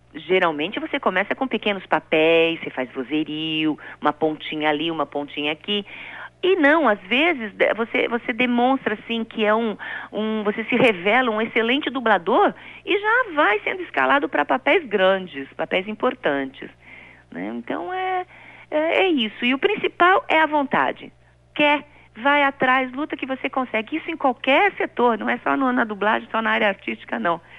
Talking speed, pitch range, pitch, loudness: 165 wpm, 185-290 Hz, 230 Hz, -21 LUFS